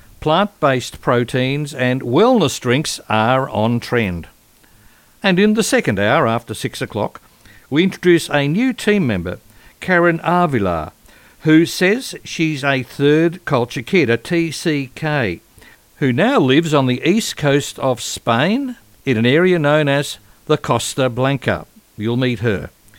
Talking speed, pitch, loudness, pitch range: 140 wpm, 135 Hz, -17 LUFS, 115-160 Hz